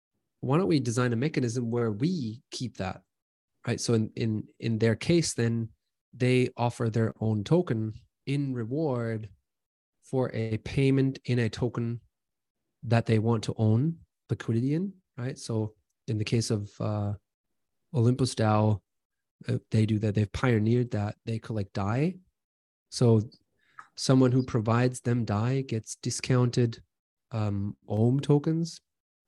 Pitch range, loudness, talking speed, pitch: 110-130 Hz, -28 LUFS, 140 wpm, 115 Hz